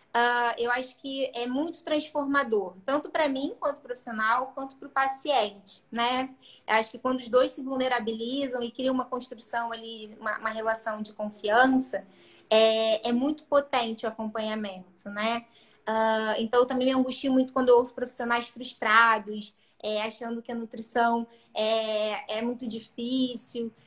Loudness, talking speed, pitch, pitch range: -27 LUFS, 155 wpm, 235 Hz, 220-260 Hz